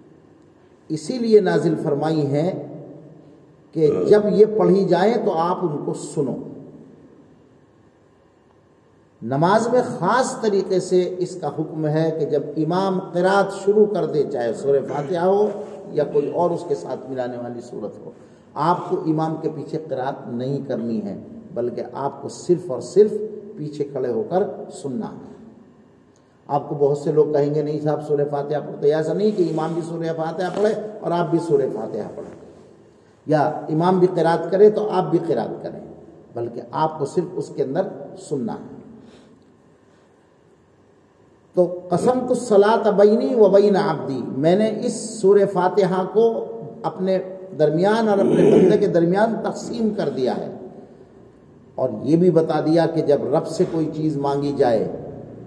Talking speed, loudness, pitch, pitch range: 160 wpm, -20 LUFS, 180 Hz, 150-205 Hz